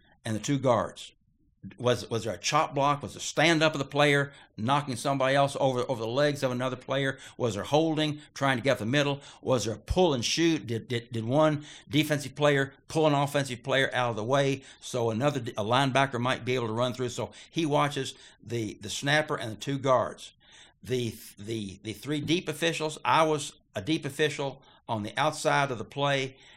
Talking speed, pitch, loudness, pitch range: 205 wpm, 135 Hz, -28 LUFS, 115-145 Hz